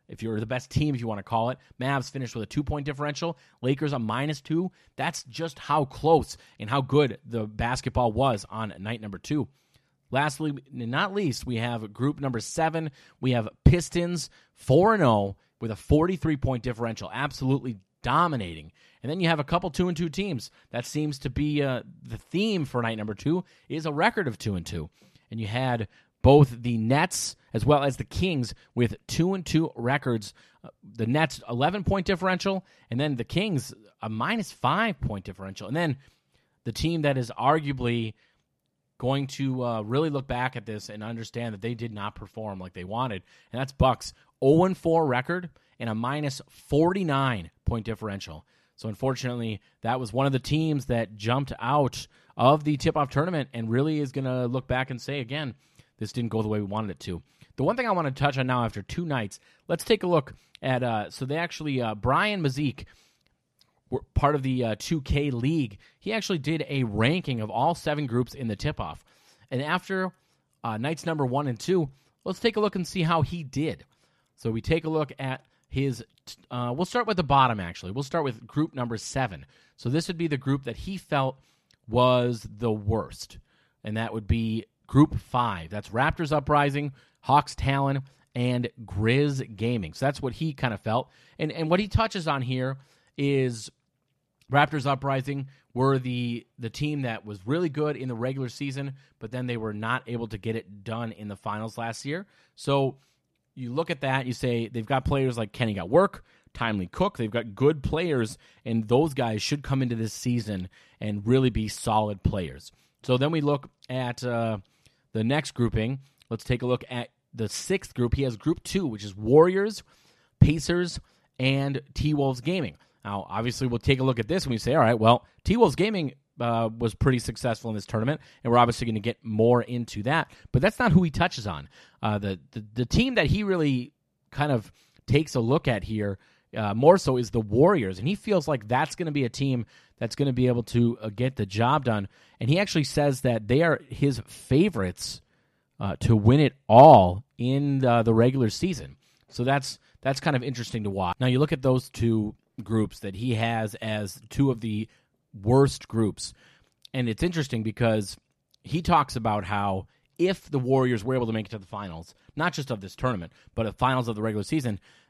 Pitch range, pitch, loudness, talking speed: 115-145 Hz, 130 Hz, -26 LUFS, 200 wpm